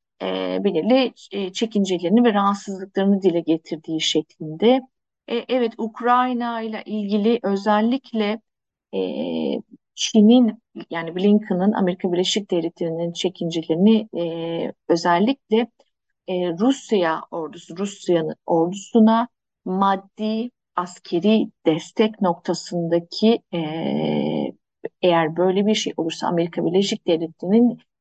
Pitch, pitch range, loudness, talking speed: 195 Hz, 170-225 Hz, -21 LUFS, 90 wpm